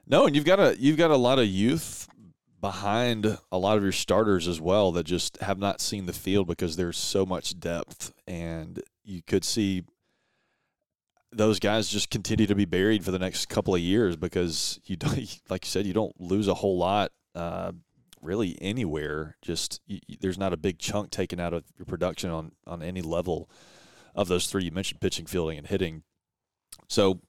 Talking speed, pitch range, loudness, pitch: 195 wpm, 85-100 Hz, -27 LUFS, 95 Hz